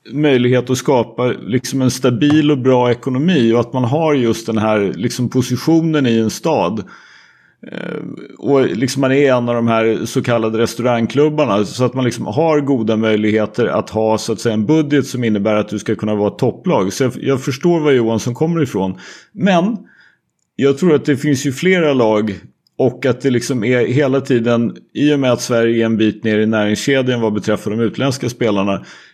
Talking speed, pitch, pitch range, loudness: 190 wpm, 125 Hz, 110-140 Hz, -15 LUFS